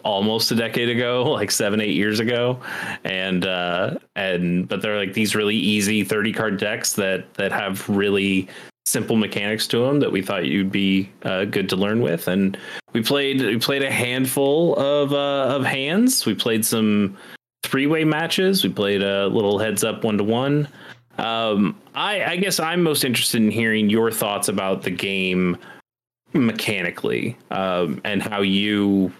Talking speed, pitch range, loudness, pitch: 175 wpm, 100-130 Hz, -21 LUFS, 110 Hz